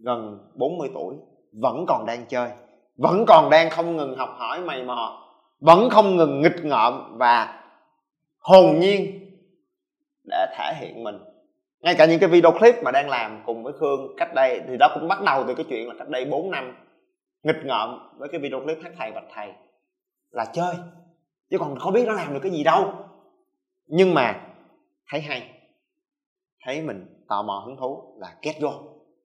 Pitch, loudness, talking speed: 185 Hz, -21 LUFS, 185 wpm